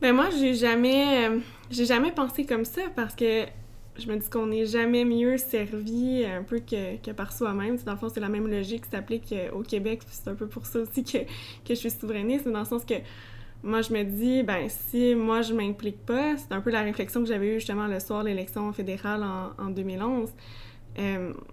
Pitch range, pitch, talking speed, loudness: 205-240 Hz, 225 Hz, 230 wpm, -28 LUFS